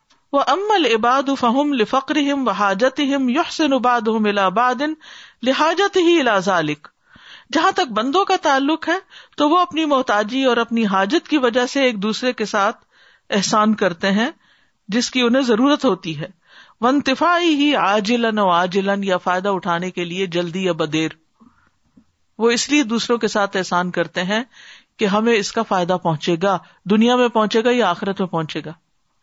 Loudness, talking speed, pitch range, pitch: -18 LUFS, 165 wpm, 195-275 Hz, 230 Hz